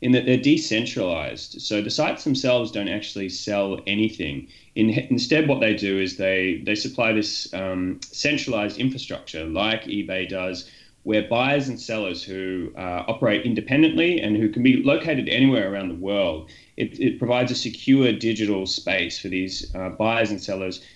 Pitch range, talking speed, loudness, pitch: 95-125 Hz, 165 wpm, -23 LUFS, 110 Hz